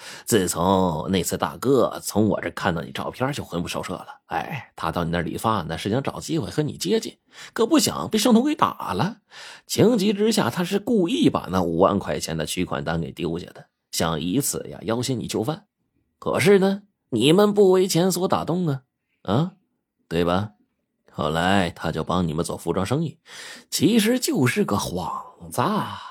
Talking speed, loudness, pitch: 260 characters per minute, -23 LUFS, 115 Hz